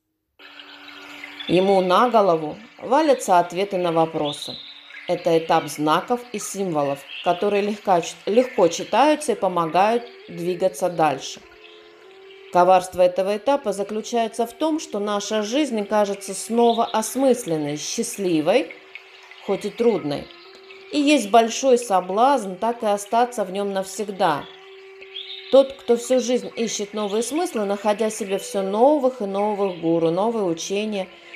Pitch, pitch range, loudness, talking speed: 205 Hz, 180-240 Hz, -21 LUFS, 115 wpm